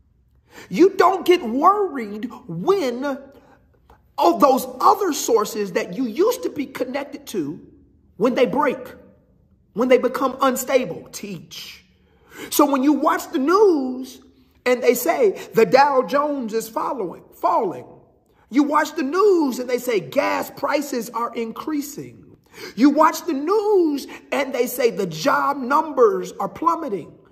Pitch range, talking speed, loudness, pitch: 250-330 Hz, 135 wpm, -20 LUFS, 280 Hz